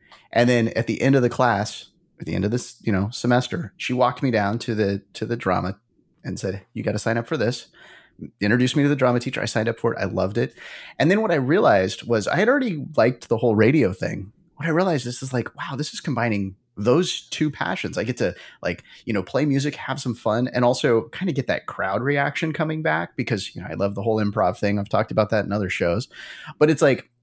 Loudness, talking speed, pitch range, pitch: -22 LUFS, 255 wpm, 105-140 Hz, 120 Hz